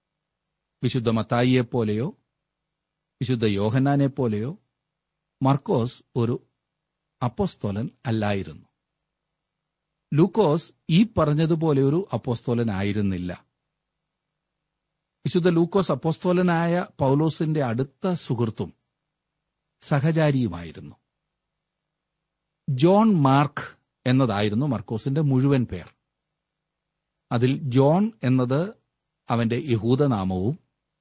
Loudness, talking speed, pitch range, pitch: -23 LUFS, 60 wpm, 120-165 Hz, 140 Hz